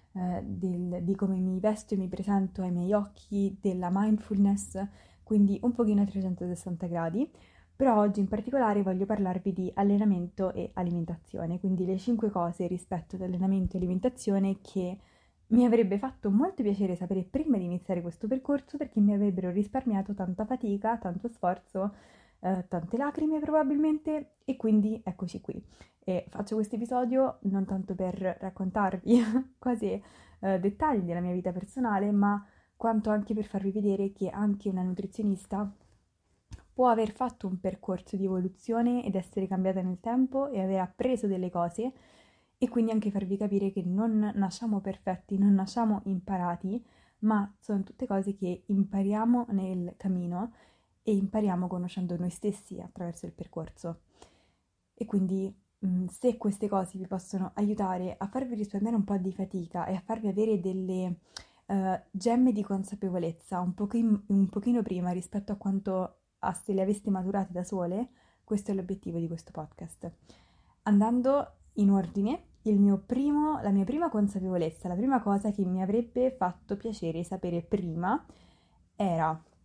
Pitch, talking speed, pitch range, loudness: 200 Hz, 150 wpm, 185-220 Hz, -30 LUFS